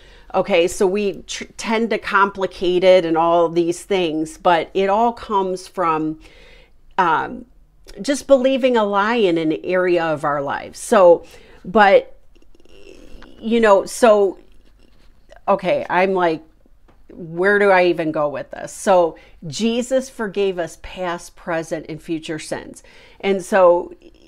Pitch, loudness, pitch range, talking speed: 195 Hz, -18 LUFS, 170-245 Hz, 135 wpm